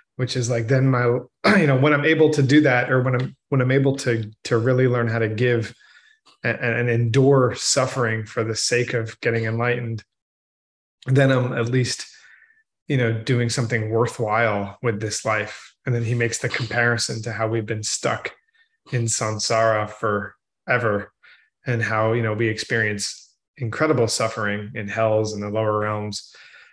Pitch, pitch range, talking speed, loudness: 120 Hz, 110-130 Hz, 170 wpm, -21 LUFS